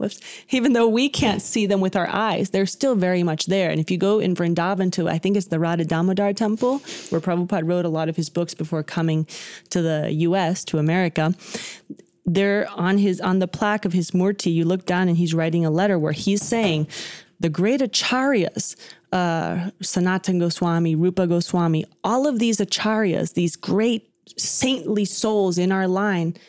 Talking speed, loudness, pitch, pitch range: 185 wpm, -21 LUFS, 185 Hz, 170-205 Hz